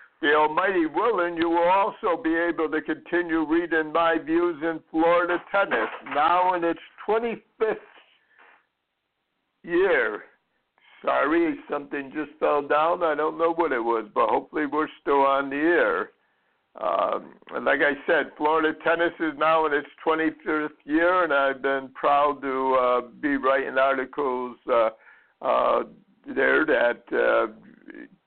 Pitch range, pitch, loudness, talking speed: 145-175 Hz, 160 Hz, -24 LUFS, 140 wpm